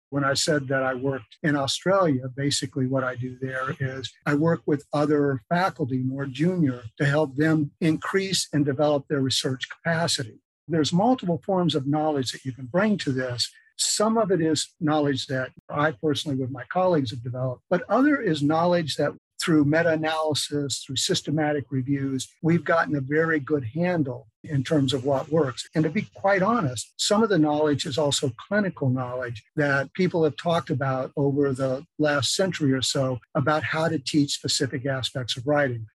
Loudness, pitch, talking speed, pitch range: -24 LUFS, 145 Hz, 180 wpm, 135-160 Hz